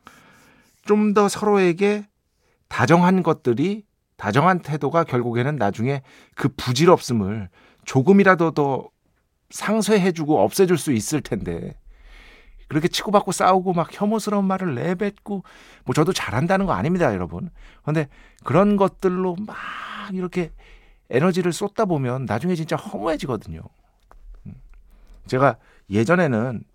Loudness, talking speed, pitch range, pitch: -21 LUFS, 280 characters per minute, 135-195 Hz, 175 Hz